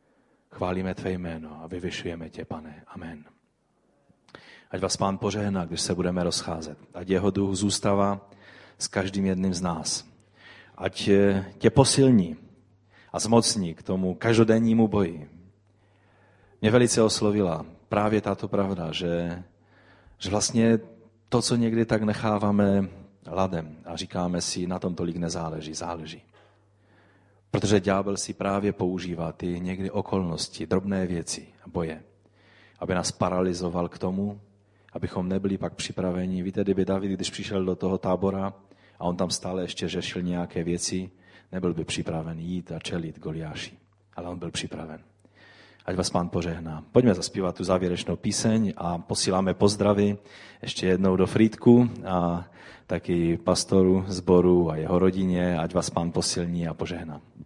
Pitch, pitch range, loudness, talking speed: 95 Hz, 85-100 Hz, -26 LUFS, 140 wpm